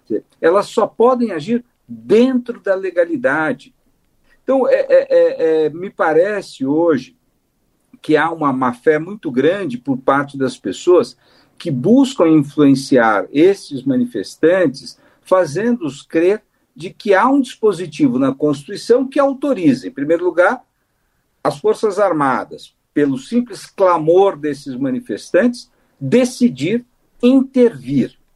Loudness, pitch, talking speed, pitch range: -16 LUFS, 235 Hz, 110 wpm, 170-270 Hz